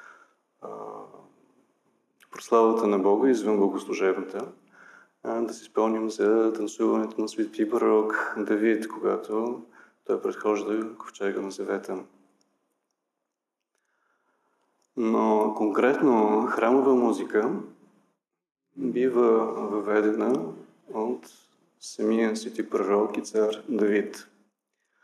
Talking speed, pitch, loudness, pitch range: 80 wpm, 110 Hz, -25 LUFS, 105-120 Hz